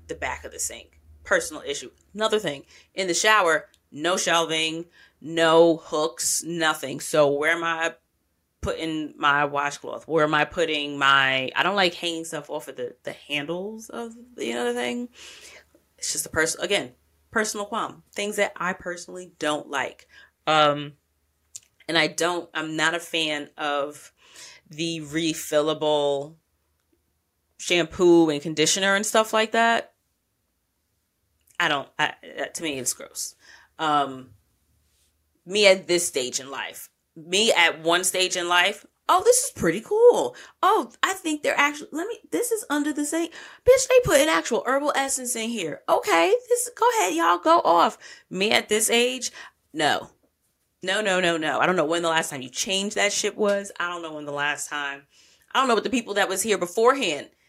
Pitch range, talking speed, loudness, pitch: 145-210 Hz, 170 wpm, -23 LUFS, 165 Hz